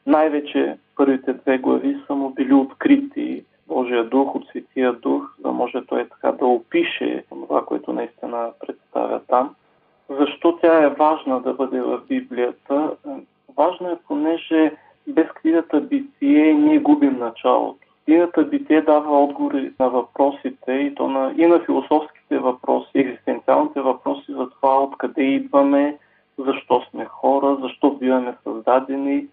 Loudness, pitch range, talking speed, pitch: -20 LUFS, 135-165 Hz, 135 wpm, 140 Hz